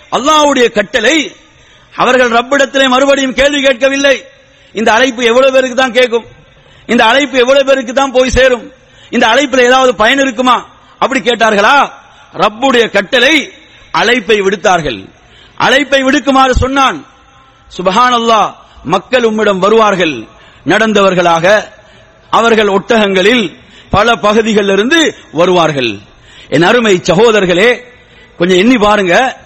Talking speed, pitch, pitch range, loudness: 100 wpm, 245 Hz, 210-270 Hz, -9 LUFS